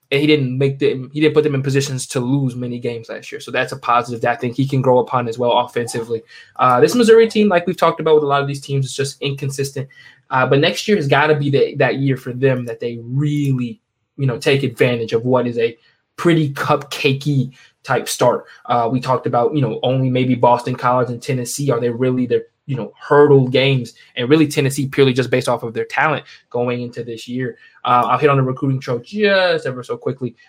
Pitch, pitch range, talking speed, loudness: 135 Hz, 120-145 Hz, 240 wpm, -17 LUFS